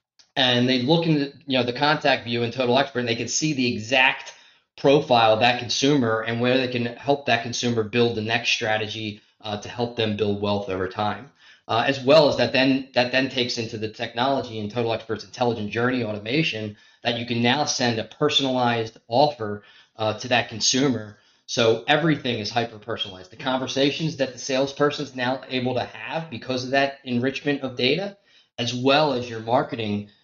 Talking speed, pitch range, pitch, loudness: 195 wpm, 110-135 Hz, 120 Hz, -23 LUFS